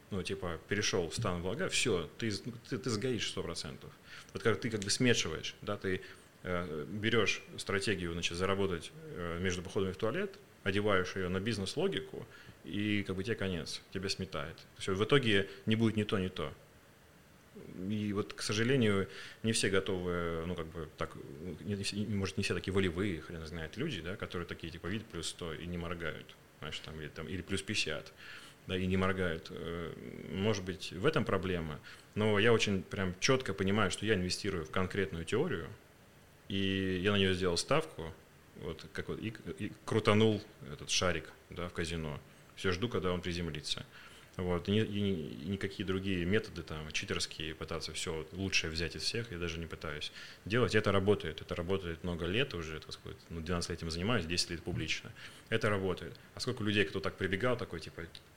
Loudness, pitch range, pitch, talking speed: -35 LUFS, 85-105 Hz, 95 Hz, 185 wpm